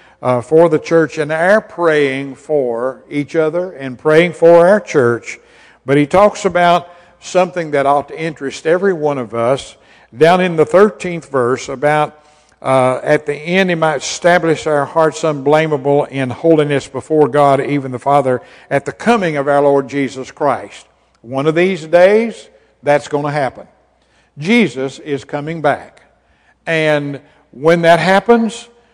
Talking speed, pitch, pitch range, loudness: 155 wpm, 150 Hz, 140-175 Hz, -14 LUFS